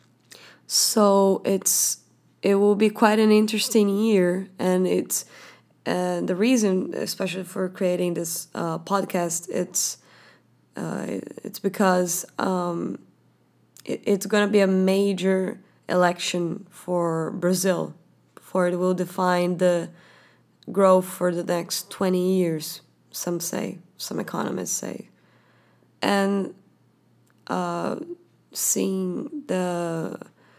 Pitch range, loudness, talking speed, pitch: 180-200 Hz, -23 LUFS, 110 wpm, 185 Hz